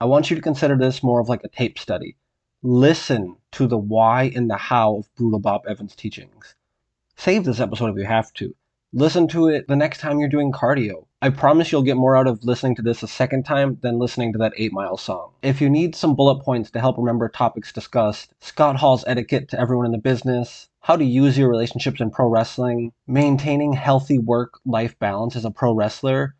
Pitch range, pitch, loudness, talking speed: 115-140 Hz, 125 Hz, -20 LUFS, 220 wpm